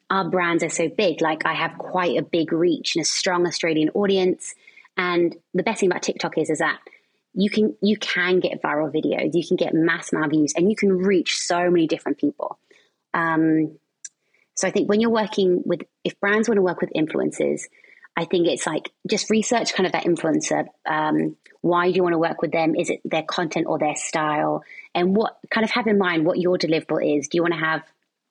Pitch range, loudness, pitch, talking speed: 165-205 Hz, -22 LUFS, 175 Hz, 225 wpm